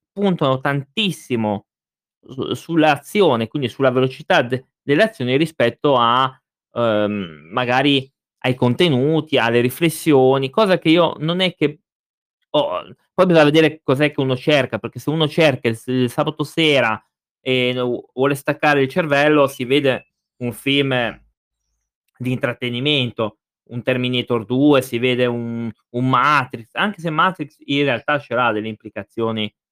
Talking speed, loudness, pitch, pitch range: 135 wpm, -18 LUFS, 130 Hz, 120-150 Hz